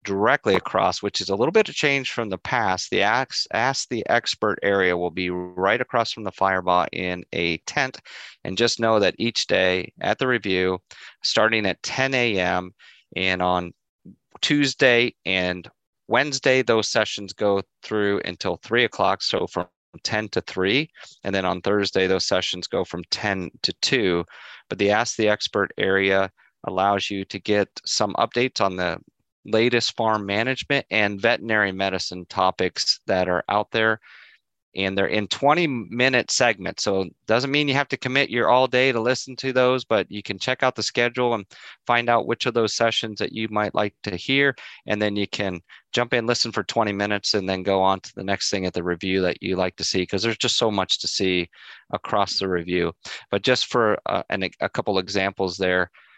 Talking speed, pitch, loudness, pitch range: 190 wpm, 100 Hz, -22 LUFS, 95-120 Hz